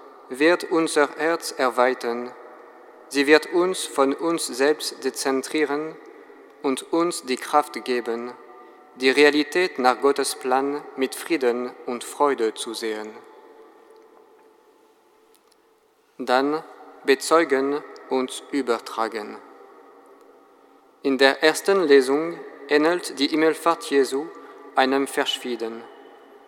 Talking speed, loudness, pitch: 95 wpm, -22 LUFS, 150 Hz